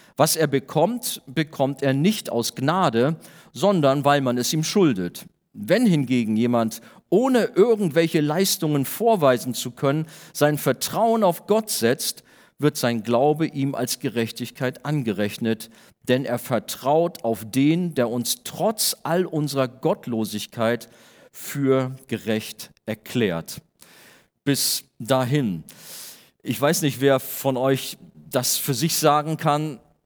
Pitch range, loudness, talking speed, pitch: 120-160 Hz, -22 LUFS, 125 wpm, 140 Hz